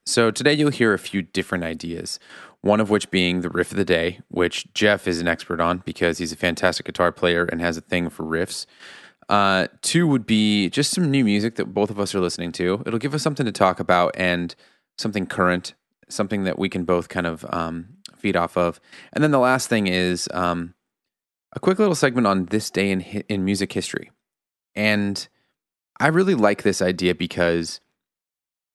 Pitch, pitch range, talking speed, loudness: 95 Hz, 90-110 Hz, 200 wpm, -22 LUFS